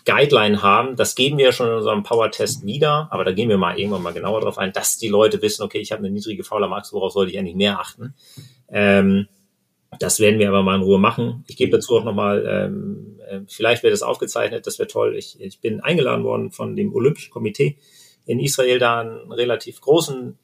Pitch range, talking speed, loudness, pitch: 100-150 Hz, 225 wpm, -19 LUFS, 115 Hz